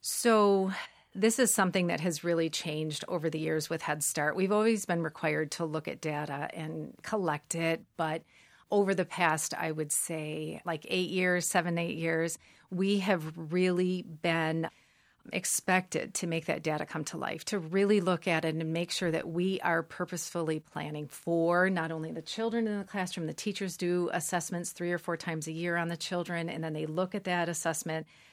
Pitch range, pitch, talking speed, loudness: 160-185 Hz, 170 Hz, 195 wpm, -31 LUFS